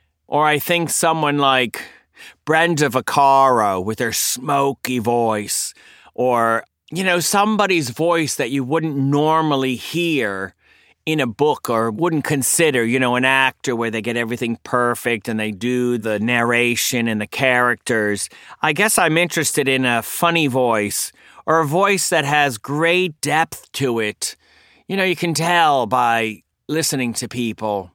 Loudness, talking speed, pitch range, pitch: -18 LUFS, 150 wpm, 120-160 Hz, 135 Hz